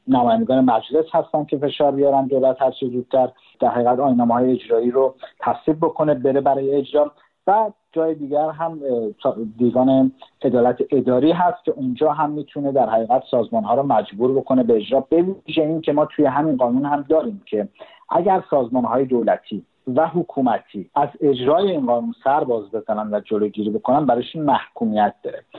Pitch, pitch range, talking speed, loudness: 135 Hz, 125-155 Hz, 165 wpm, -19 LUFS